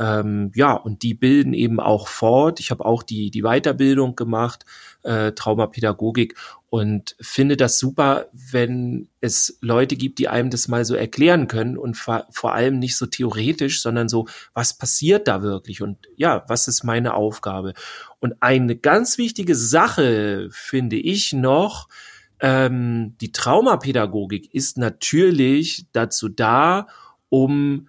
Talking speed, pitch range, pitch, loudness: 140 wpm, 110-135 Hz, 120 Hz, -19 LUFS